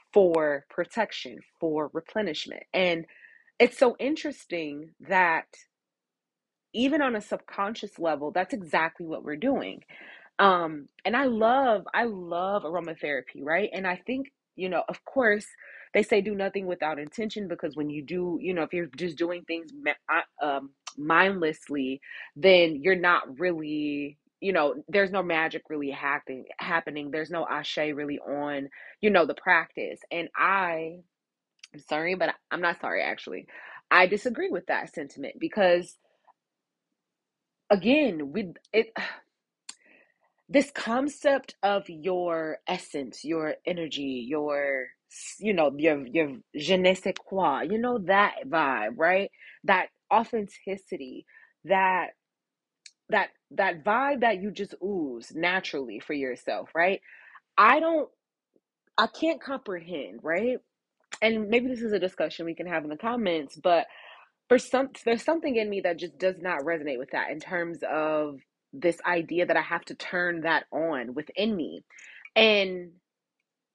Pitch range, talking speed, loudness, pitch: 155-220 Hz, 140 wpm, -27 LUFS, 180 Hz